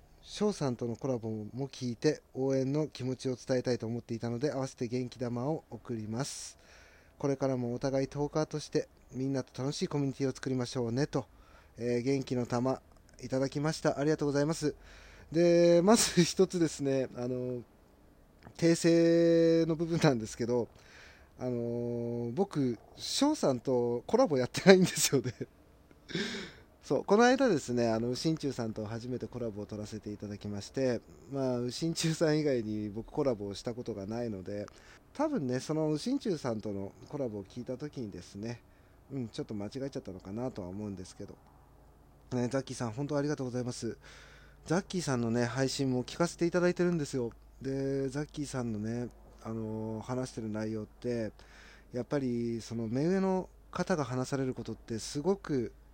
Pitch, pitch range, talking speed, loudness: 125 Hz, 110-145 Hz, 355 characters per minute, -32 LUFS